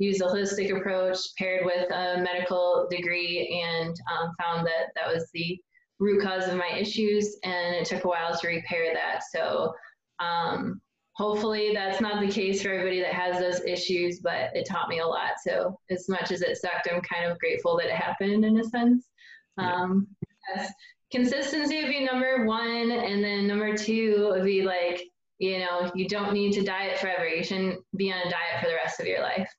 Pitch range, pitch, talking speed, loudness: 175-210 Hz, 190 Hz, 200 wpm, -27 LUFS